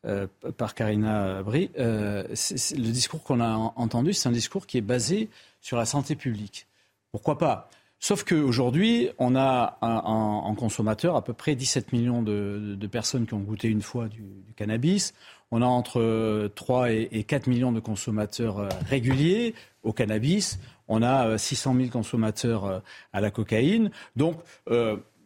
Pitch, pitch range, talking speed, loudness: 115 Hz, 110-135 Hz, 165 wpm, -26 LUFS